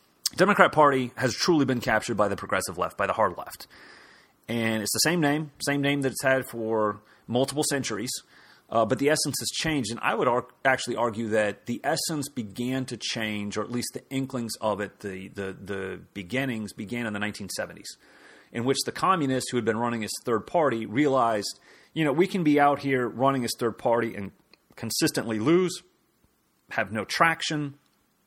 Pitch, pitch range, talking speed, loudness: 120 Hz, 110-140 Hz, 190 wpm, -26 LUFS